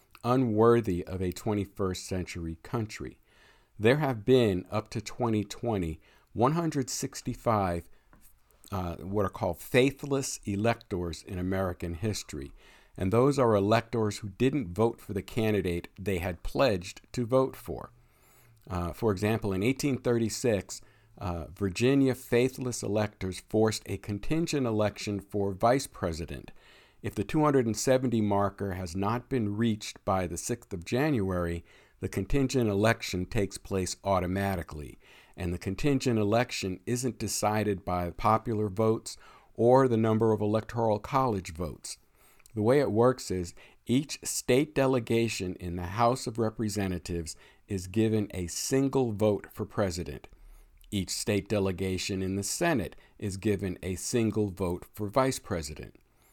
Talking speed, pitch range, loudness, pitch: 130 wpm, 95-120 Hz, -29 LUFS, 105 Hz